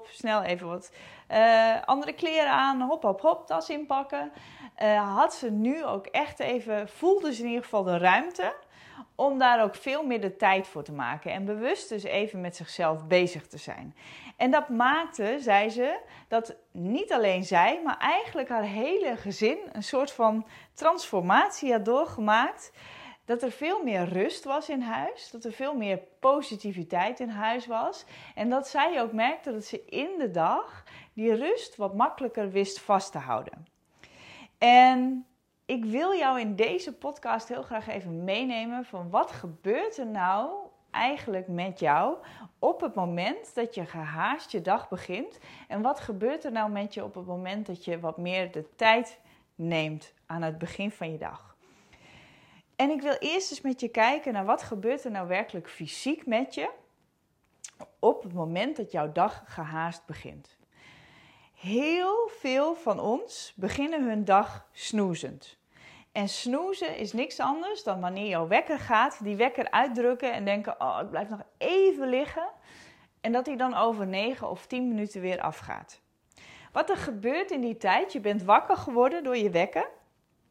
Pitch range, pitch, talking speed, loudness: 195-265 Hz, 225 Hz, 170 wpm, -28 LUFS